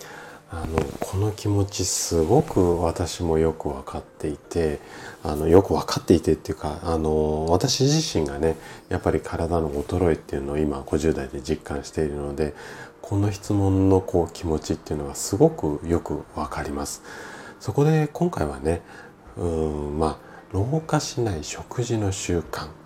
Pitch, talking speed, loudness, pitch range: 80 Hz, 300 characters per minute, -24 LUFS, 75-100 Hz